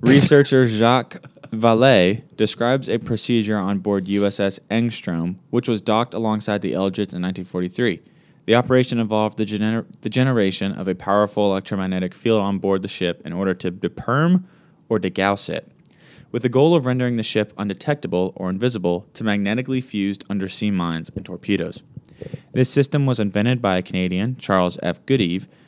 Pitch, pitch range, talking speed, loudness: 105 Hz, 95-125 Hz, 160 wpm, -20 LUFS